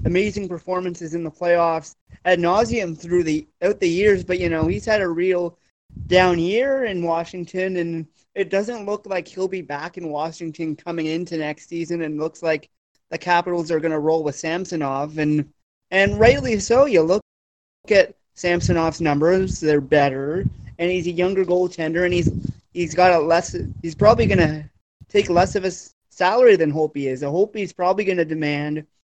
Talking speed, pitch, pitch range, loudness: 190 wpm, 170 Hz, 155-185 Hz, -20 LUFS